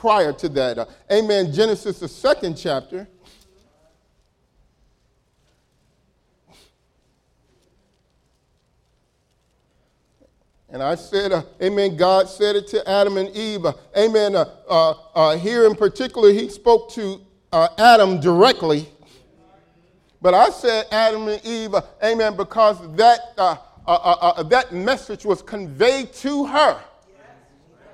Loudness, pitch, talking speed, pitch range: -18 LUFS, 205 Hz, 120 wpm, 185-225 Hz